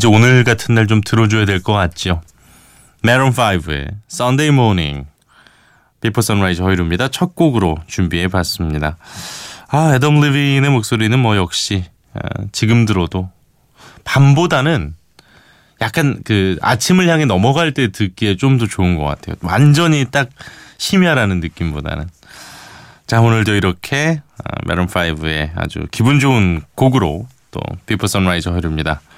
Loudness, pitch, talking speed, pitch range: -15 LUFS, 110 Hz, 325 characters per minute, 90-130 Hz